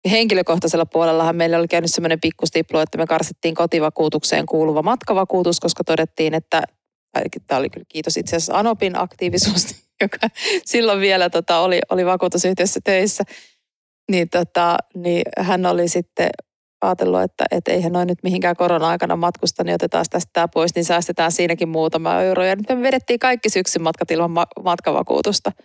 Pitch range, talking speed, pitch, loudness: 165-185 Hz, 150 wpm, 175 Hz, -18 LUFS